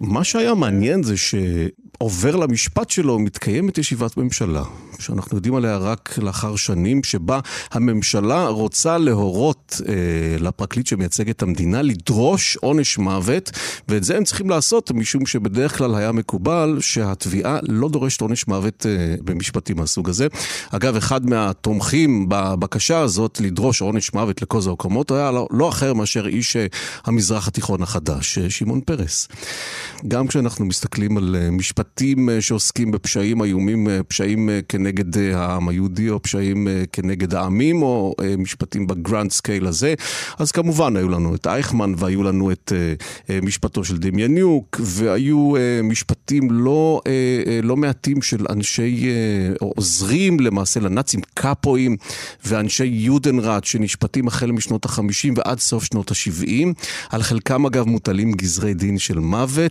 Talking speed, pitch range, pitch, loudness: 130 wpm, 100-130 Hz, 110 Hz, -19 LUFS